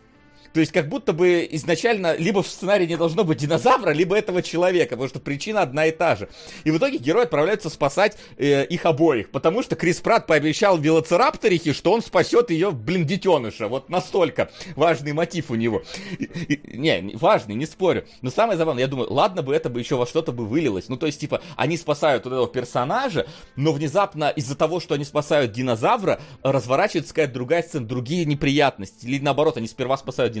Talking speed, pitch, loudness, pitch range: 195 wpm, 160 Hz, -22 LUFS, 140-175 Hz